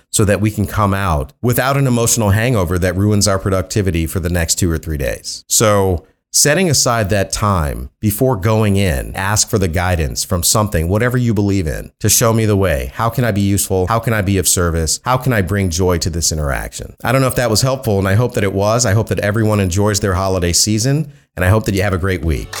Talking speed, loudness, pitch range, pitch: 245 wpm, -15 LUFS, 90-115 Hz, 100 Hz